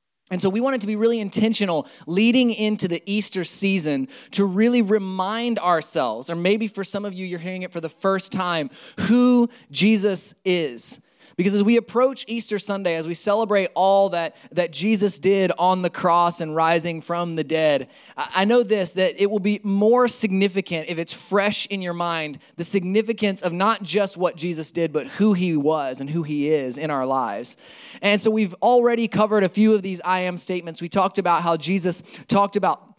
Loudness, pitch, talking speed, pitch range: -21 LUFS, 190 Hz, 200 wpm, 170-210 Hz